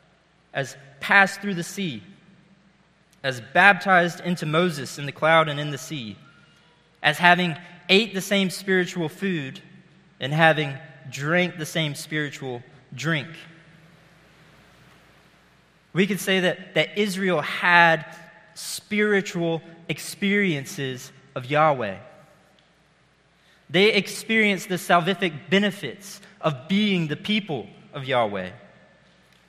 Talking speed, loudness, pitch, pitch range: 105 wpm, -22 LUFS, 170 Hz, 155-190 Hz